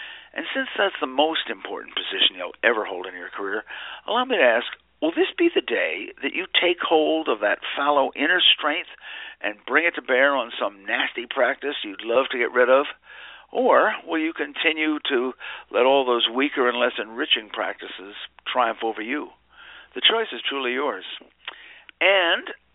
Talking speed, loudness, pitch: 180 wpm, -22 LUFS, 175 Hz